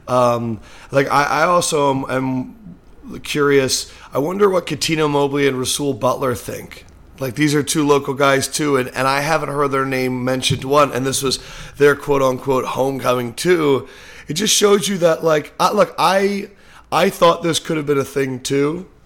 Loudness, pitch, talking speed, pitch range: -17 LUFS, 140 Hz, 185 wpm, 130-155 Hz